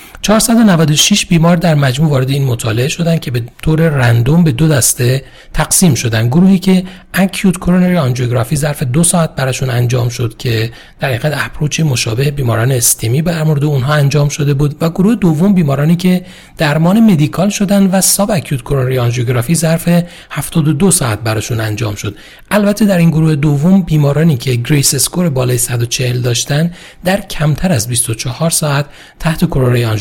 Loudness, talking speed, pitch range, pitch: -12 LUFS, 160 wpm, 130-175 Hz, 150 Hz